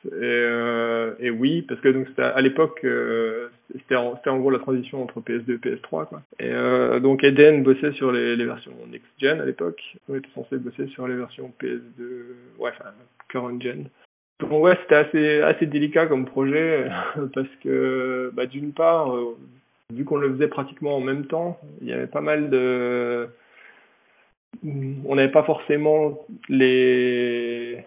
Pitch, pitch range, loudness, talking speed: 130 Hz, 120-145 Hz, -22 LUFS, 170 wpm